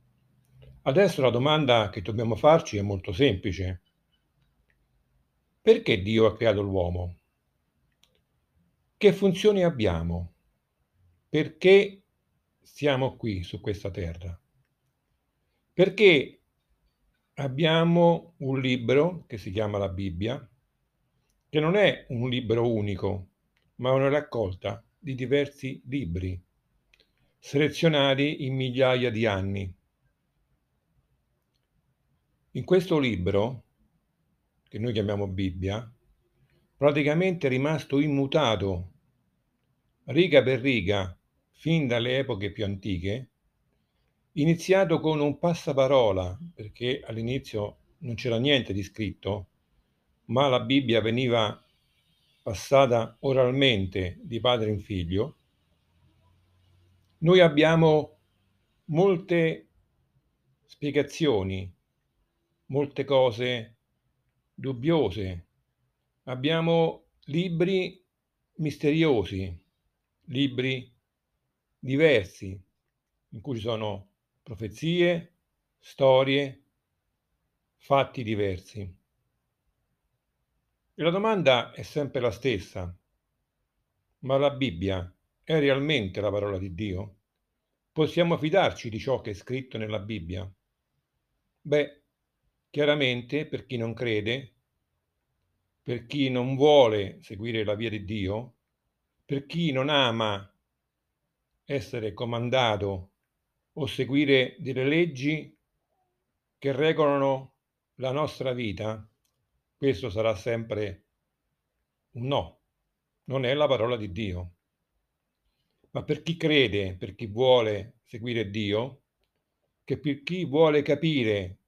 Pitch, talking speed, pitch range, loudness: 120 Hz, 95 wpm, 100-145 Hz, -26 LUFS